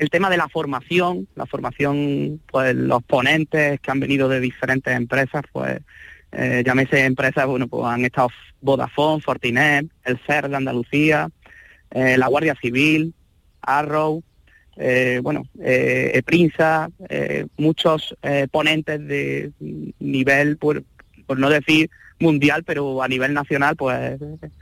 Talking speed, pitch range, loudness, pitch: 135 wpm, 125-155 Hz, -19 LUFS, 140 Hz